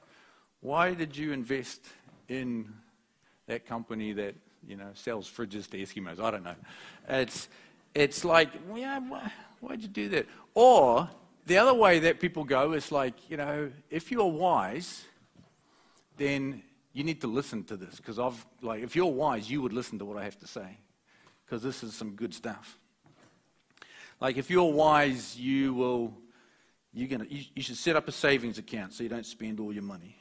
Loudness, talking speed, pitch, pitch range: -29 LUFS, 180 wpm, 130 Hz, 115-155 Hz